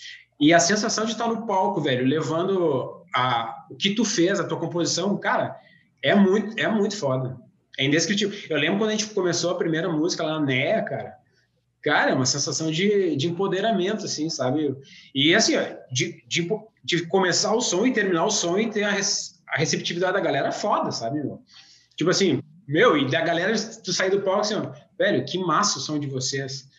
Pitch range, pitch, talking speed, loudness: 160-205 Hz, 180 Hz, 195 wpm, -23 LUFS